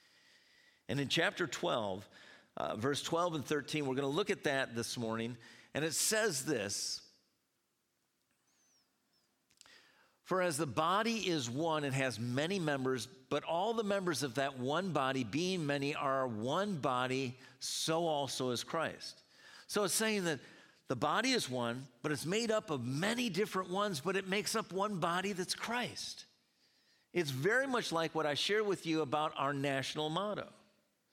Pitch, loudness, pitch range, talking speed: 155 Hz, -36 LUFS, 135-185 Hz, 165 wpm